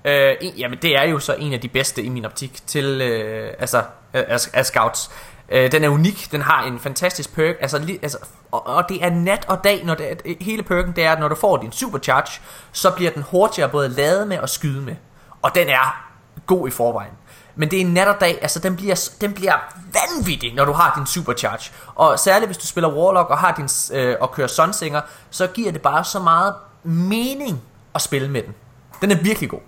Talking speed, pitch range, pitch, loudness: 230 wpm, 135-185 Hz, 155 Hz, -19 LUFS